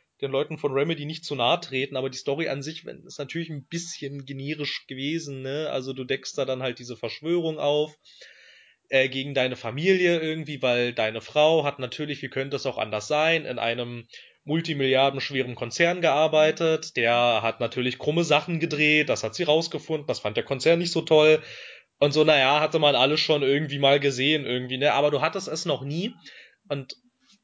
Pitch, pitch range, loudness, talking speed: 145 Hz, 135-155 Hz, -24 LUFS, 190 wpm